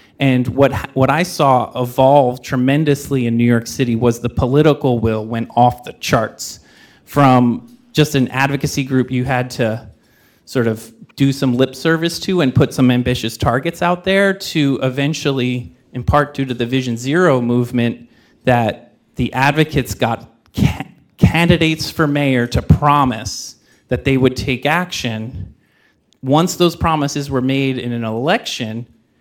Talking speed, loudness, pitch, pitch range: 150 wpm, -16 LUFS, 130 Hz, 120-145 Hz